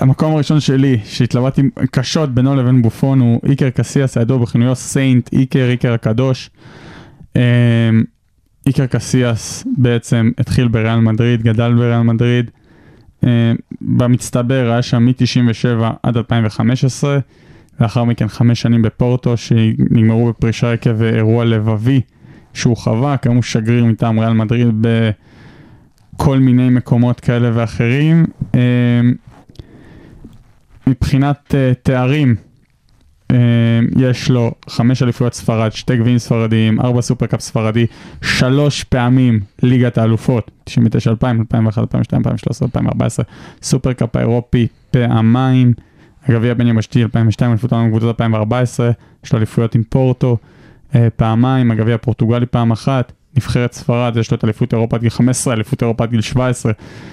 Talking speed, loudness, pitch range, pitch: 125 wpm, -14 LUFS, 115-130 Hz, 120 Hz